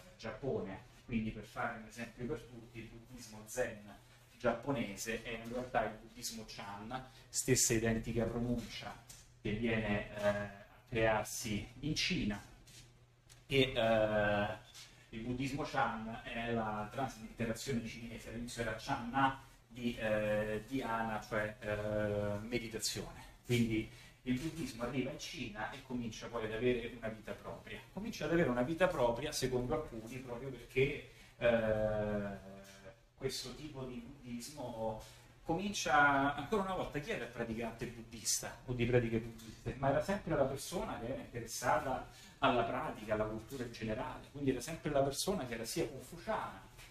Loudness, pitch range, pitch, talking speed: -38 LUFS, 110-130 Hz, 120 Hz, 145 wpm